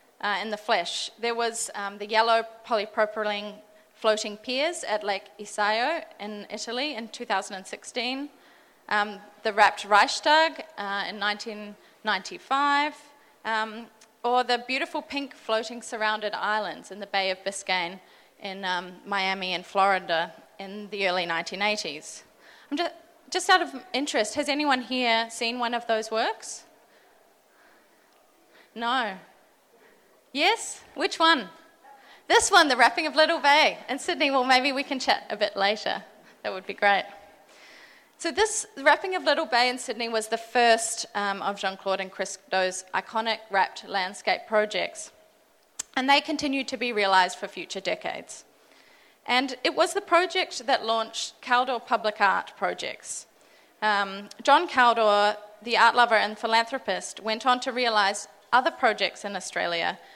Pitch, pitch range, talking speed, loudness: 225 Hz, 205-270 Hz, 145 wpm, -25 LUFS